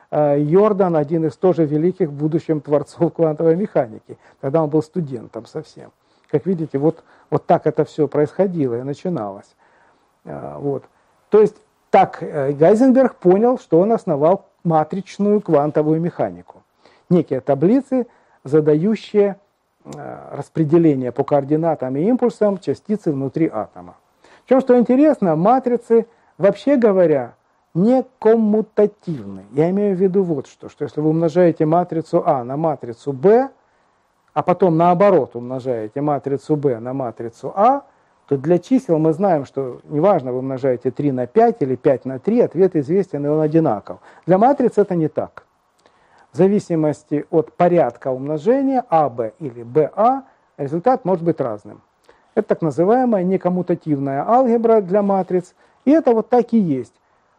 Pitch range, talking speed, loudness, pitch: 145-205 Hz, 135 wpm, -18 LUFS, 165 Hz